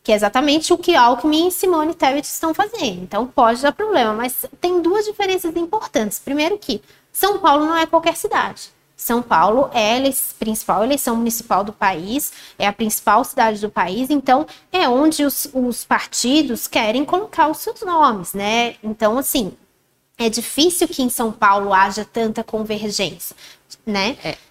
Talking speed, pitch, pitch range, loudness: 165 wpm, 260 Hz, 220-320 Hz, -18 LUFS